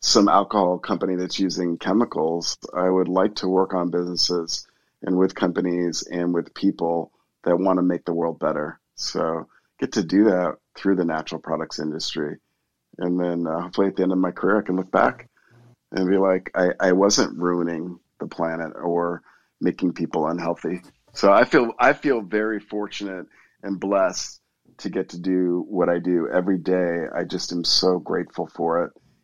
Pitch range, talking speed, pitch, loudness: 85-95 Hz, 180 wpm, 90 Hz, -23 LUFS